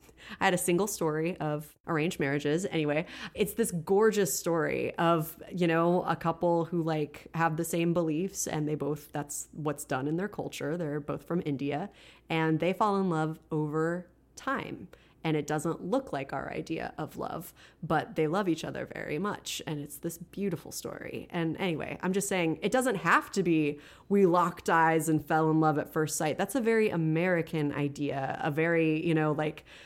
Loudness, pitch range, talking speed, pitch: -30 LUFS, 155-175 Hz, 190 wpm, 165 Hz